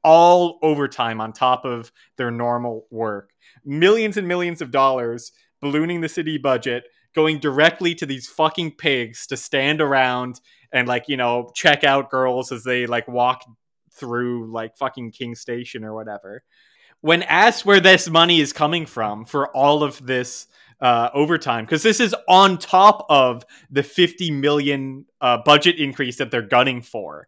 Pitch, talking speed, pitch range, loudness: 135 Hz, 165 wpm, 120-160 Hz, -18 LUFS